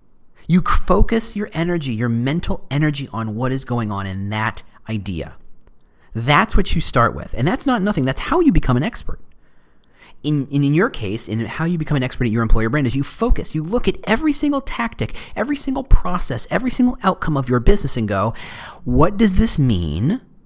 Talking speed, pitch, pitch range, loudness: 200 wpm, 140 Hz, 115-195 Hz, -19 LUFS